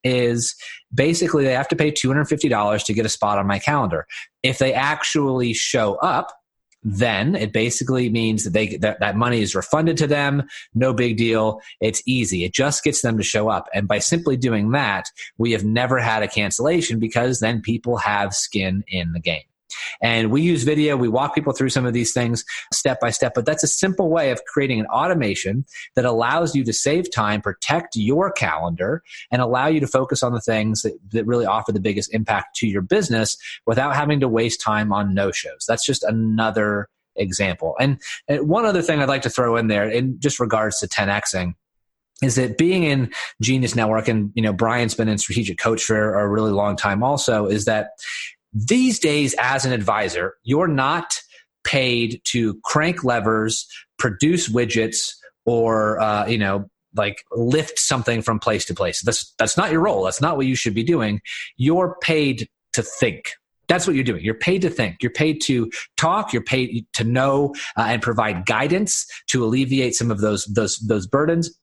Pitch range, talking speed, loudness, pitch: 110-135 Hz, 195 wpm, -20 LUFS, 120 Hz